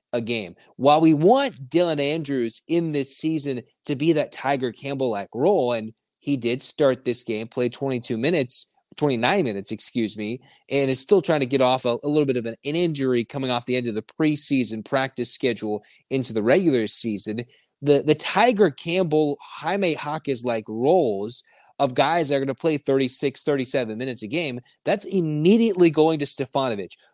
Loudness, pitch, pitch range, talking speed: -22 LUFS, 135 Hz, 120-155 Hz, 185 wpm